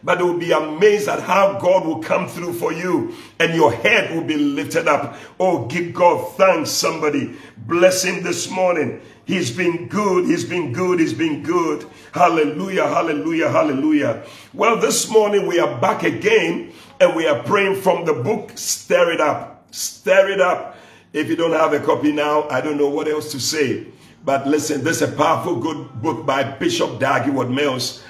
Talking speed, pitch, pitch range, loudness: 185 wpm, 175 Hz, 150-195 Hz, -18 LUFS